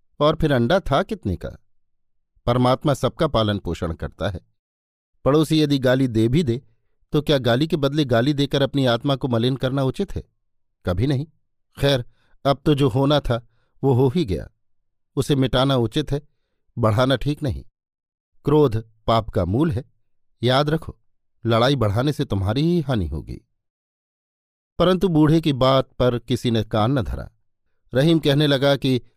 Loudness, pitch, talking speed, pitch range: -21 LUFS, 130 Hz, 165 wpm, 110-145 Hz